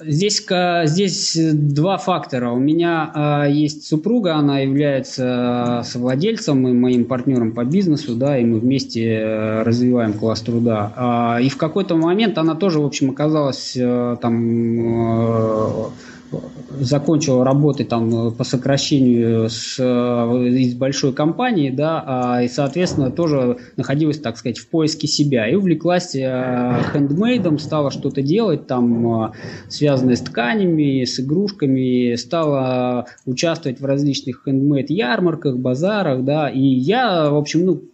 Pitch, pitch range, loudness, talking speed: 135 Hz, 125-155 Hz, -18 LUFS, 120 wpm